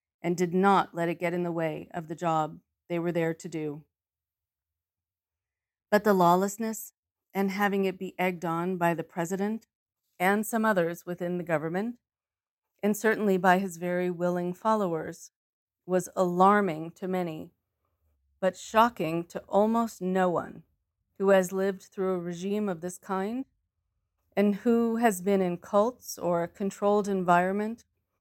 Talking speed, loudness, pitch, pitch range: 150 wpm, -28 LUFS, 180 Hz, 165-200 Hz